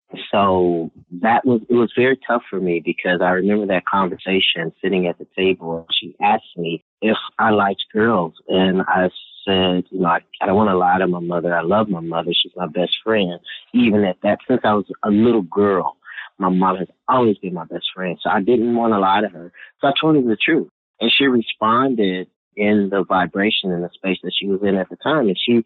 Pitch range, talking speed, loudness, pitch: 90-110 Hz, 225 wpm, -18 LUFS, 95 Hz